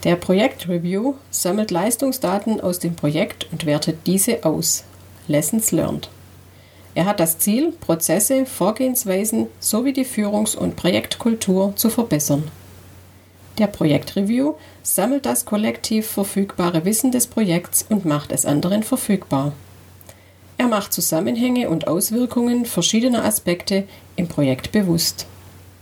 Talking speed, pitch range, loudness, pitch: 120 wpm, 145-220 Hz, -19 LUFS, 180 Hz